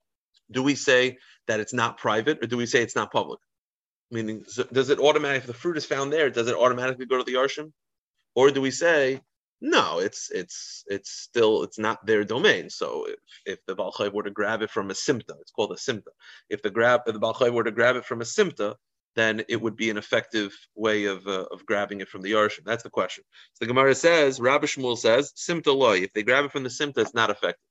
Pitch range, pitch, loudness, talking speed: 115-145 Hz, 125 Hz, -24 LUFS, 235 wpm